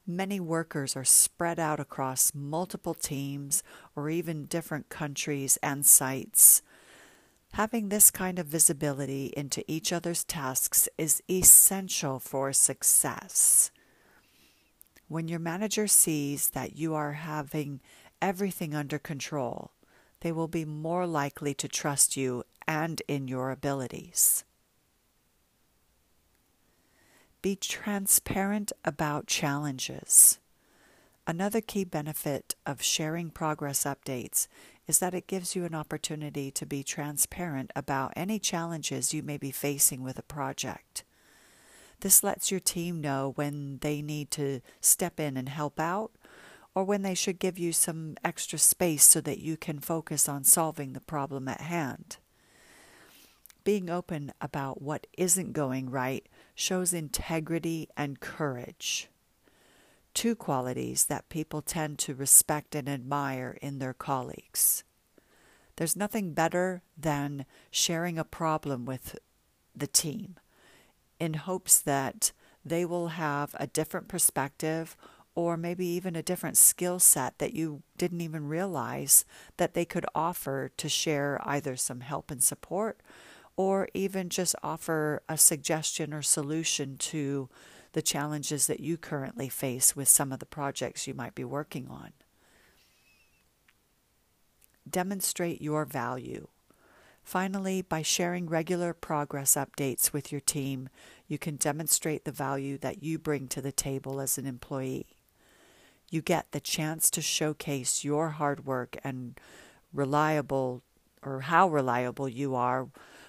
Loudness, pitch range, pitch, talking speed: -27 LUFS, 140-170 Hz, 150 Hz, 130 wpm